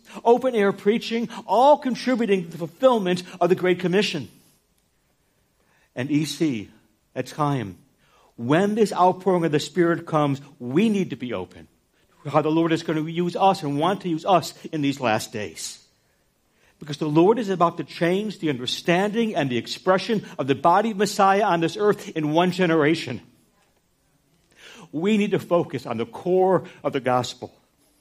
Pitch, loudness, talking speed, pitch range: 170 Hz, -22 LUFS, 170 wpm, 145-195 Hz